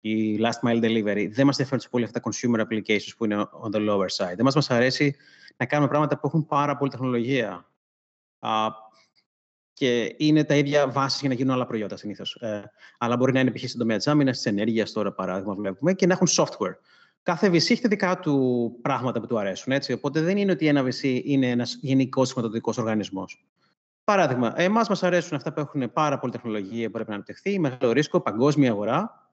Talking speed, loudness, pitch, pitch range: 205 wpm, -24 LUFS, 125 Hz, 110-145 Hz